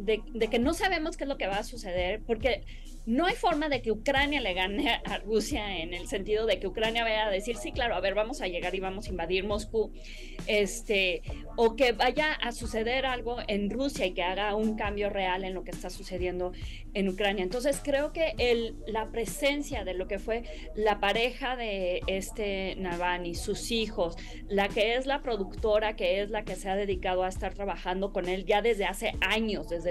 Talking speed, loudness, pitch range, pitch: 210 wpm, -30 LUFS, 190-240 Hz, 210 Hz